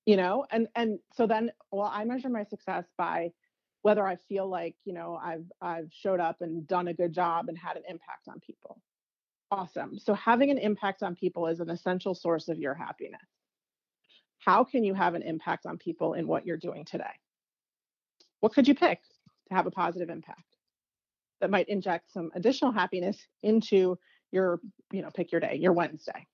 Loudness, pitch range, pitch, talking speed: -30 LUFS, 170-210 Hz, 185 Hz, 190 wpm